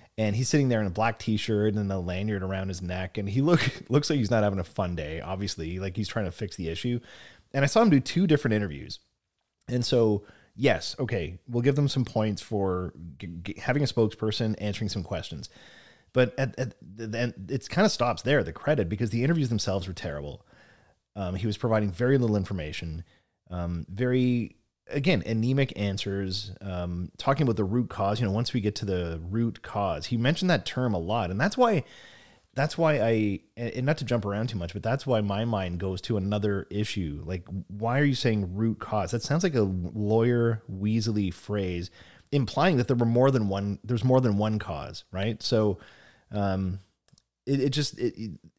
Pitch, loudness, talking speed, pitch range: 110 Hz, -27 LUFS, 205 wpm, 95-125 Hz